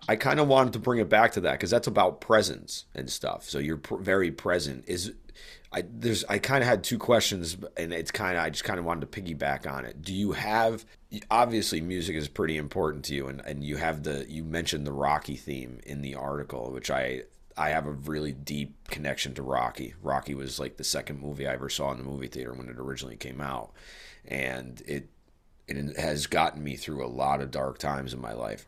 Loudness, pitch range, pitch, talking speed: -29 LUFS, 70-80 Hz, 70 Hz, 230 wpm